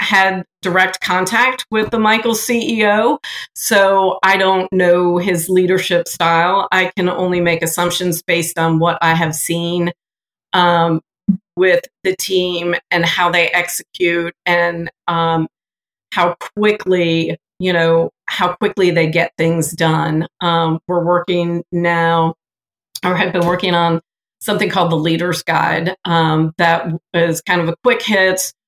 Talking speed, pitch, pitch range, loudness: 140 wpm, 175 Hz, 170-185 Hz, -15 LUFS